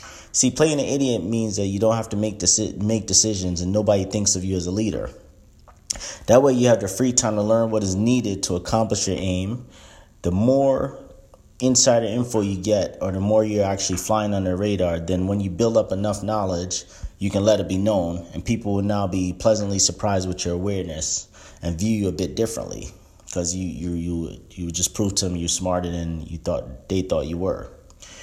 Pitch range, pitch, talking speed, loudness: 90-110 Hz, 100 Hz, 210 wpm, -22 LUFS